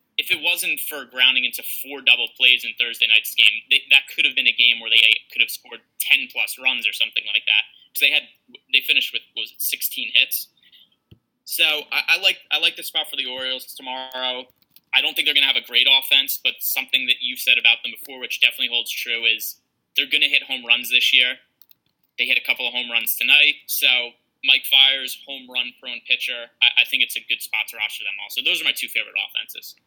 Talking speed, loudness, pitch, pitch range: 240 wpm, -18 LUFS, 130 Hz, 120-135 Hz